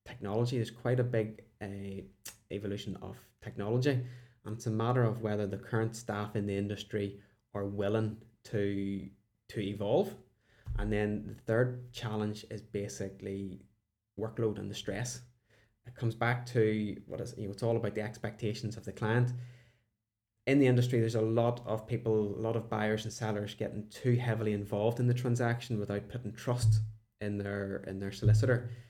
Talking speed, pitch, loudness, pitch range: 170 wpm, 110 Hz, -34 LUFS, 105-120 Hz